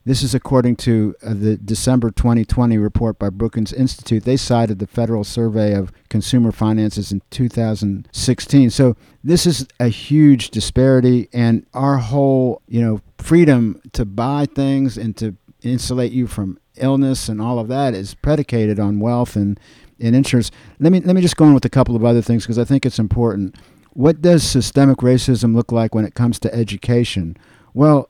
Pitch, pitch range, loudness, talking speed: 120 Hz, 110-130 Hz, -16 LUFS, 175 wpm